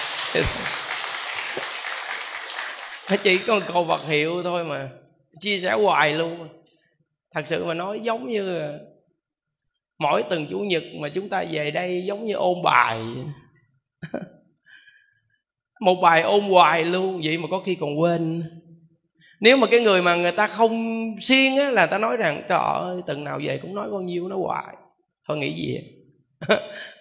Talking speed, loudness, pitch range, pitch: 160 wpm, -22 LUFS, 160-205 Hz, 175 Hz